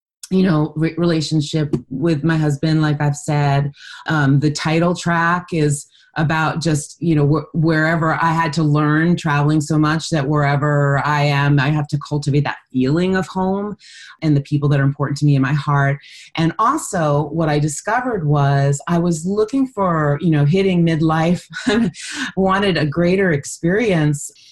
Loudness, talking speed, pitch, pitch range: -17 LUFS, 170 wpm, 155 Hz, 145-170 Hz